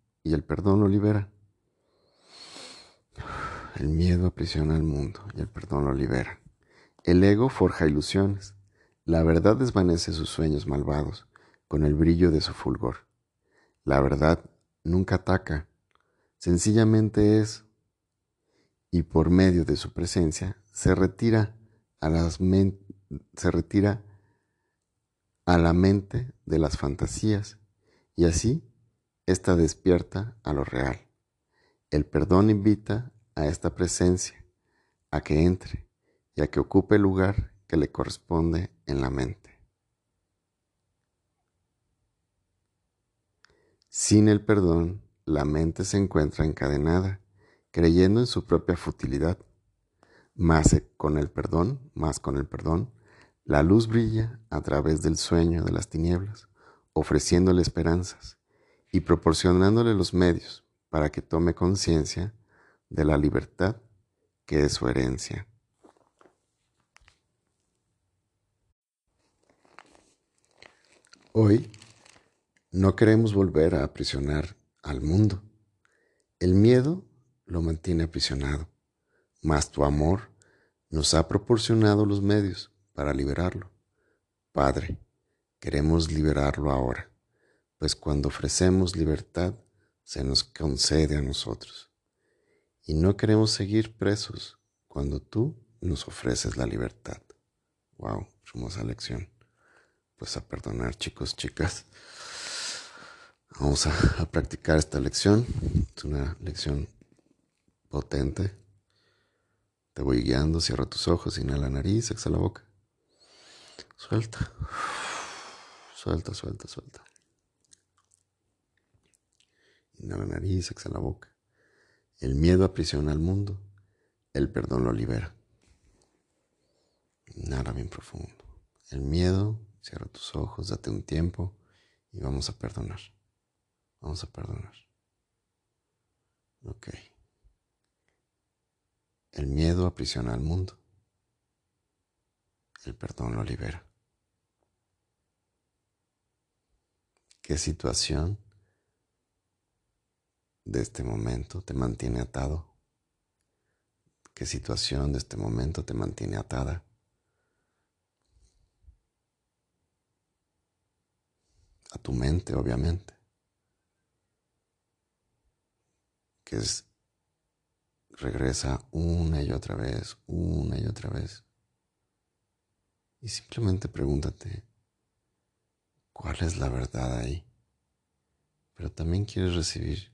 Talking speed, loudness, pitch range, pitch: 100 wpm, -27 LUFS, 80-105 Hz, 90 Hz